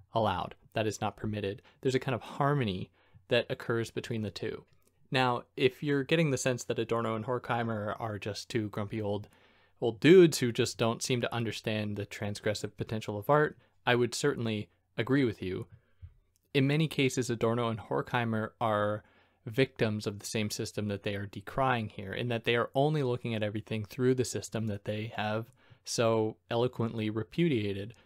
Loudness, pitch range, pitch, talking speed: -31 LUFS, 105-125 Hz, 115 Hz, 180 wpm